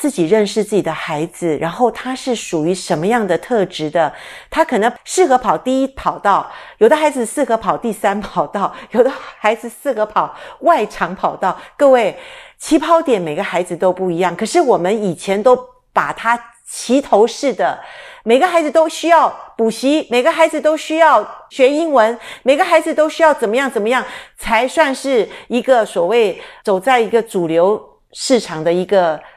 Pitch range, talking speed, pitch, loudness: 200-305 Hz, 265 characters per minute, 245 Hz, -15 LUFS